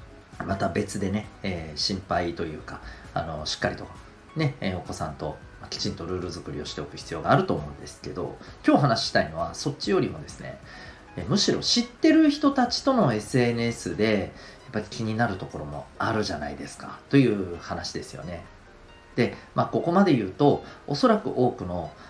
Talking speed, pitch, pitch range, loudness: 355 characters per minute, 105 Hz, 85-125 Hz, -26 LUFS